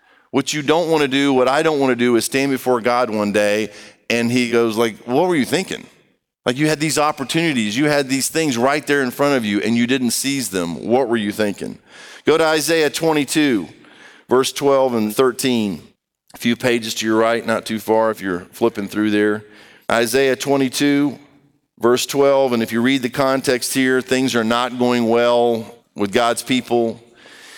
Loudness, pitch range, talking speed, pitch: -18 LUFS, 115-140 Hz, 200 wpm, 125 Hz